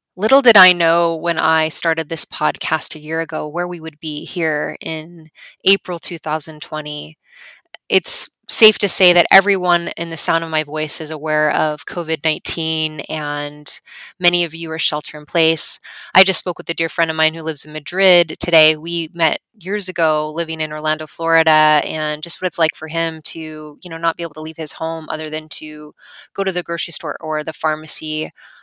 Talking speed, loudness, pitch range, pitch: 195 wpm, -17 LUFS, 155-170 Hz, 160 Hz